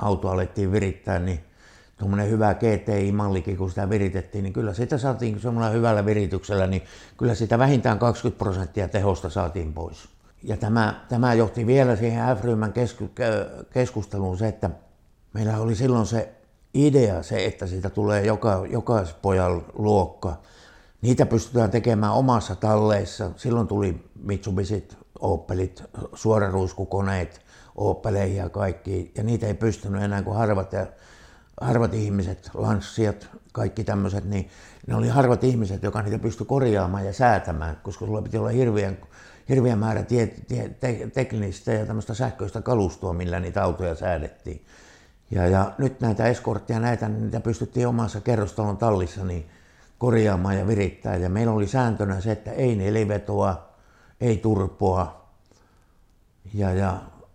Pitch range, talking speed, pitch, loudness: 95-115 Hz, 140 wpm, 105 Hz, -24 LUFS